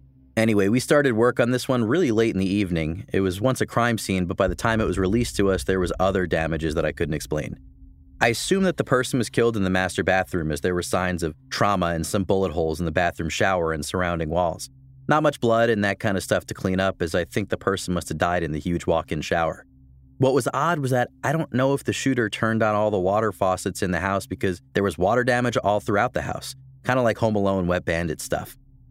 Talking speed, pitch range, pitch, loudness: 255 wpm, 90-120 Hz, 100 Hz, -23 LUFS